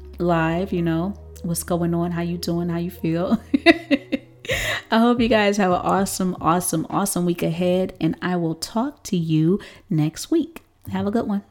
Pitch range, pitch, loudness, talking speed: 170-210 Hz, 180 Hz, -22 LUFS, 185 wpm